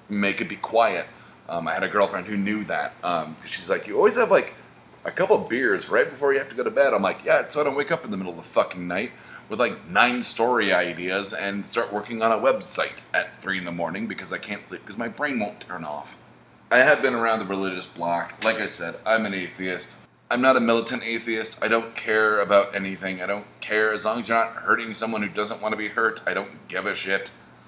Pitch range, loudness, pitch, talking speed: 95-115 Hz, -24 LUFS, 105 Hz, 250 wpm